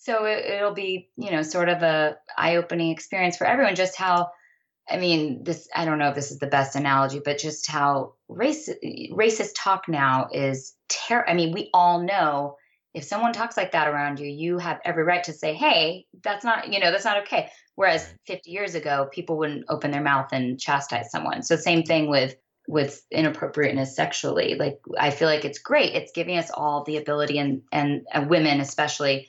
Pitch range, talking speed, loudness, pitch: 145-185 Hz, 200 wpm, -24 LUFS, 160 Hz